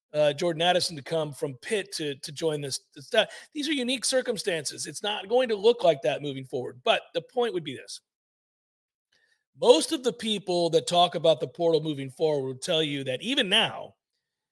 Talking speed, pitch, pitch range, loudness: 200 wpm, 175 Hz, 155-255 Hz, -26 LUFS